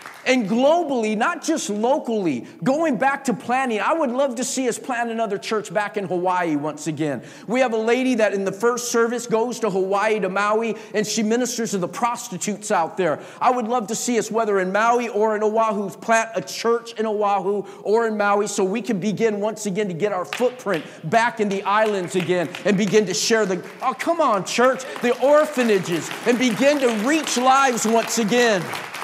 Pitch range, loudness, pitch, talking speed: 200-245 Hz, -21 LUFS, 225 Hz, 200 wpm